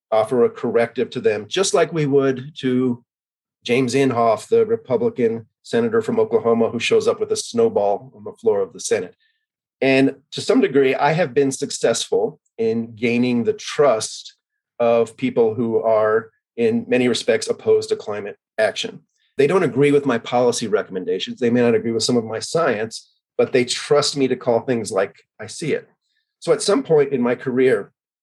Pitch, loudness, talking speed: 135 Hz, -19 LUFS, 185 wpm